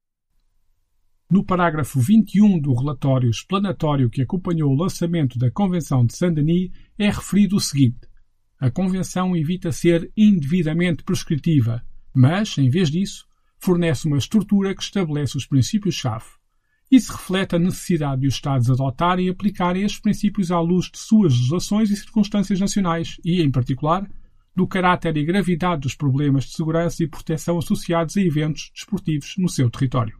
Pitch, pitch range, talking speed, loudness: 170 Hz, 135-185 Hz, 150 wpm, -20 LUFS